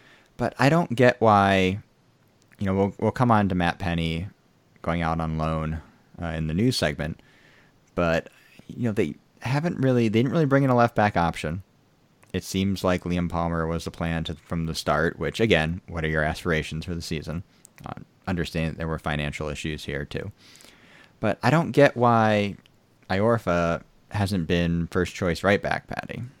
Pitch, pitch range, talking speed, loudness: 90 Hz, 80-115 Hz, 180 wpm, -24 LUFS